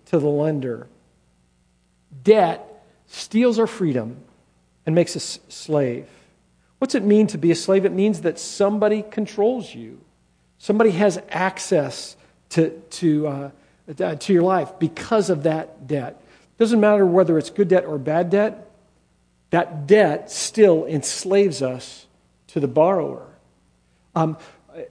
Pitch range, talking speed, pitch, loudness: 135-205 Hz, 130 wpm, 165 Hz, -20 LUFS